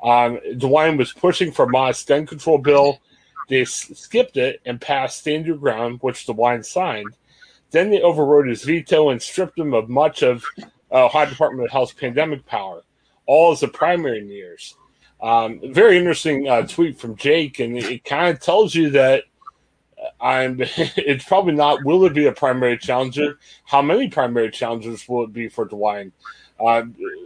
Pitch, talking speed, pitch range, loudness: 140 Hz, 175 wpm, 120-165 Hz, -18 LUFS